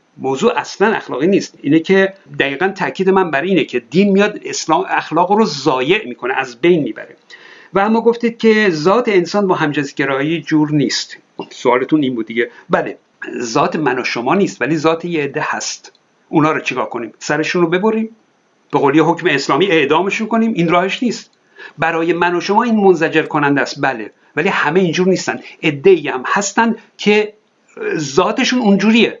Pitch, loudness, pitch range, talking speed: 185 Hz, -15 LUFS, 155-220 Hz, 170 wpm